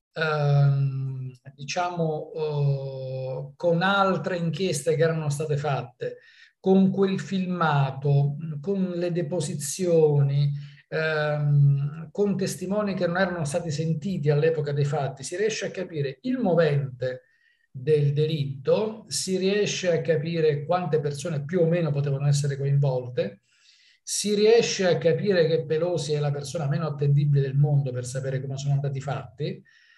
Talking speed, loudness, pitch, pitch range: 130 wpm, -25 LUFS, 155 Hz, 140-180 Hz